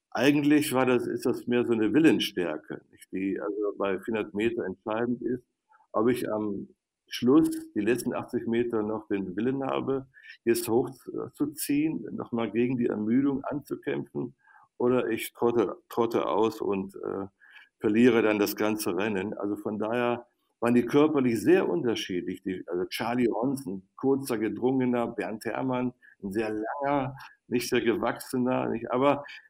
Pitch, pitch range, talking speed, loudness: 120 Hz, 110-135 Hz, 150 wpm, -28 LUFS